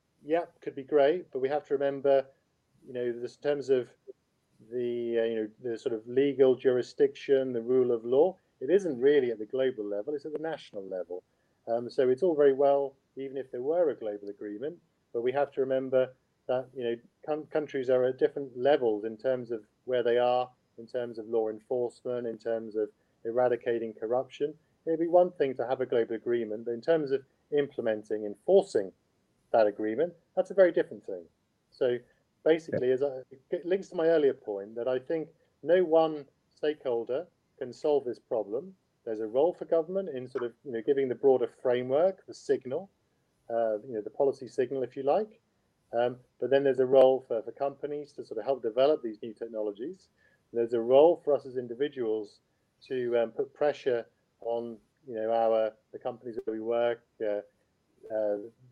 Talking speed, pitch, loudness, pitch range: 195 wpm, 130 Hz, -30 LUFS, 115-150 Hz